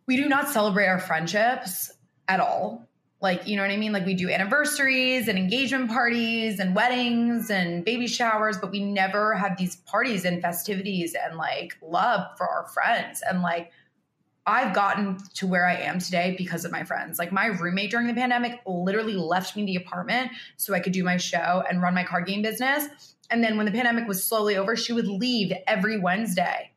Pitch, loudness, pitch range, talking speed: 200 Hz, -25 LUFS, 180-235 Hz, 200 wpm